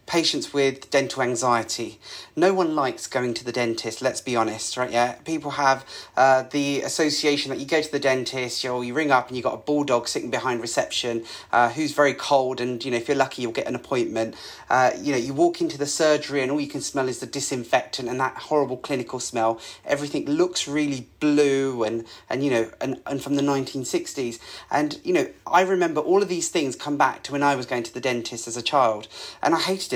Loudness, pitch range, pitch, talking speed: -24 LUFS, 120-145 Hz, 135 Hz, 230 wpm